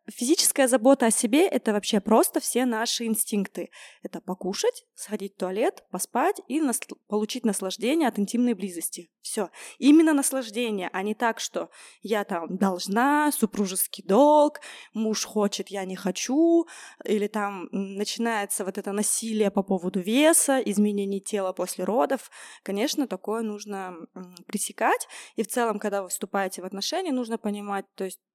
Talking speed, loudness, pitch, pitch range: 145 wpm, -25 LUFS, 215 Hz, 195-260 Hz